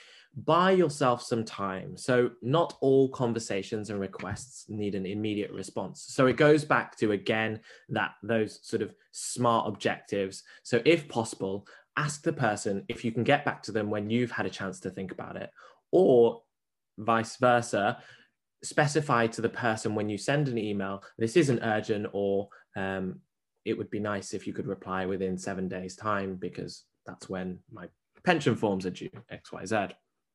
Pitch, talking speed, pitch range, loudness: 110 Hz, 170 wpm, 100-125 Hz, -29 LUFS